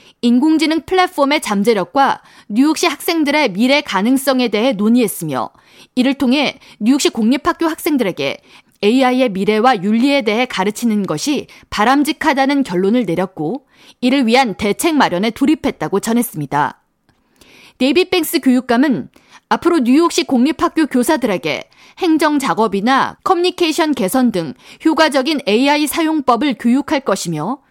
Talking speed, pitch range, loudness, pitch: 325 characters per minute, 220-300 Hz, -15 LUFS, 260 Hz